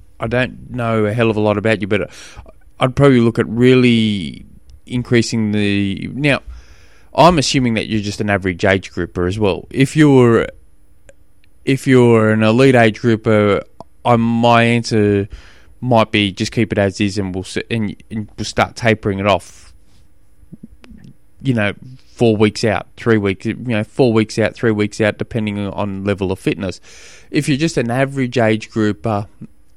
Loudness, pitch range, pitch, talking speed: -16 LUFS, 100-120 Hz, 110 Hz, 170 wpm